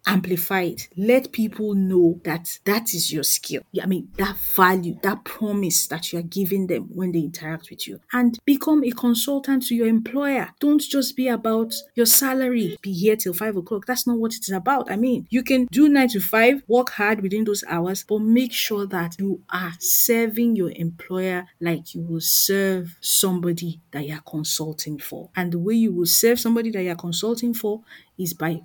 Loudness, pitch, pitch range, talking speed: -21 LUFS, 200 Hz, 175-235 Hz, 200 wpm